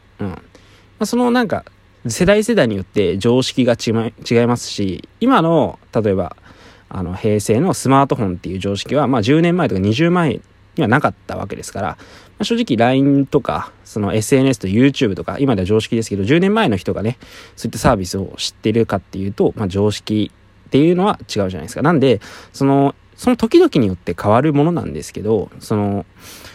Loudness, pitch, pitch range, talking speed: -17 LUFS, 115 Hz, 100-140 Hz, 395 characters per minute